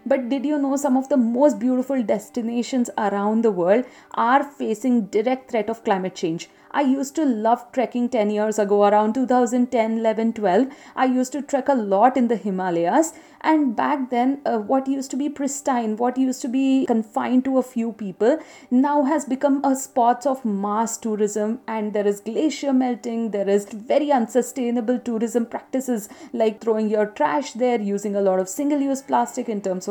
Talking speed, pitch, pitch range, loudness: 185 wpm, 245 Hz, 220-270 Hz, -22 LUFS